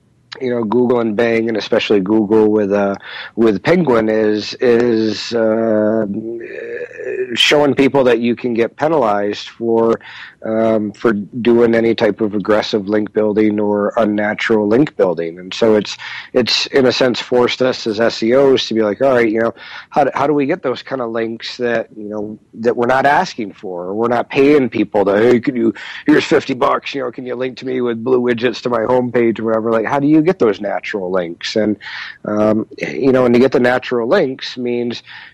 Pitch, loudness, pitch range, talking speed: 115 Hz, -15 LUFS, 110-125 Hz, 200 wpm